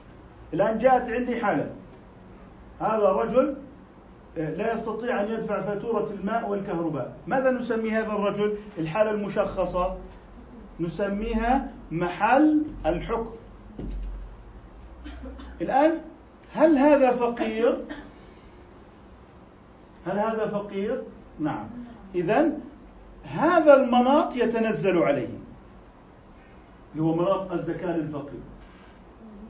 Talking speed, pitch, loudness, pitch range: 80 wpm, 215 Hz, -25 LUFS, 190-250 Hz